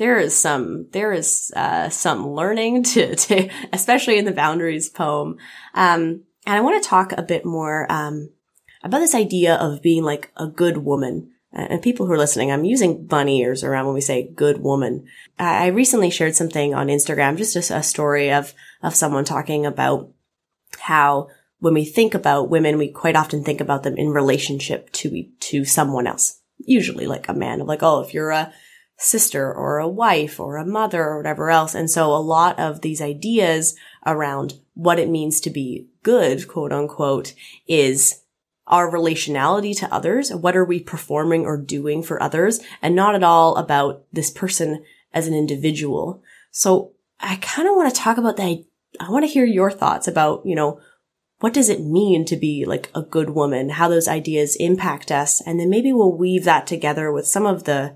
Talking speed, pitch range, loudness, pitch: 195 wpm, 150-185 Hz, -19 LUFS, 160 Hz